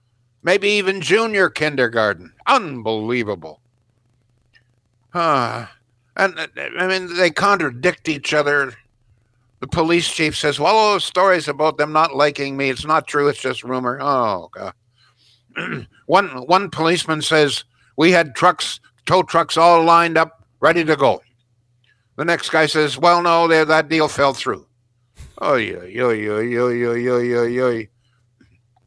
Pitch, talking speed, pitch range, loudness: 140 Hz, 135 wpm, 120-165 Hz, -17 LUFS